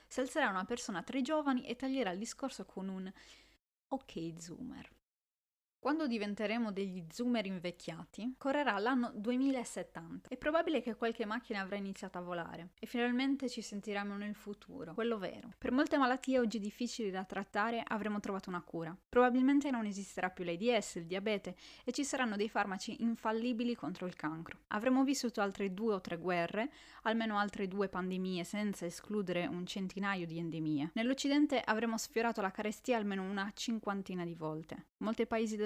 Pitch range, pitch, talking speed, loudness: 190-245 Hz, 210 Hz, 160 wpm, -37 LUFS